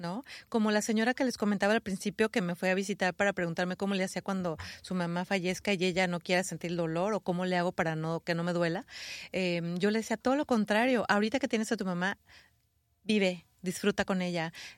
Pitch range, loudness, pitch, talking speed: 175-210 Hz, -31 LUFS, 190 Hz, 230 wpm